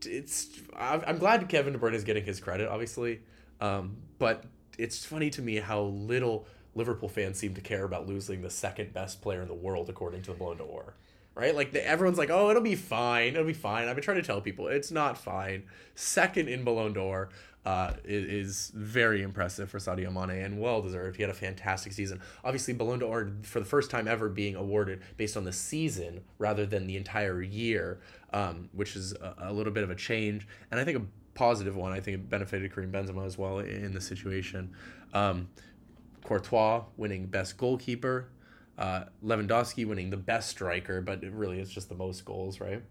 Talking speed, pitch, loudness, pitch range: 200 wpm, 100 Hz, -32 LUFS, 95-115 Hz